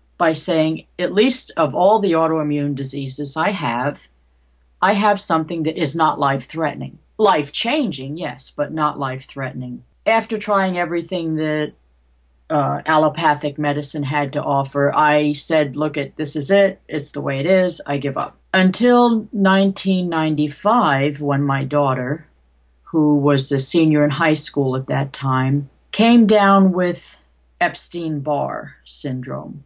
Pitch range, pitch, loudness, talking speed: 140-175 Hz, 150 Hz, -18 LUFS, 145 wpm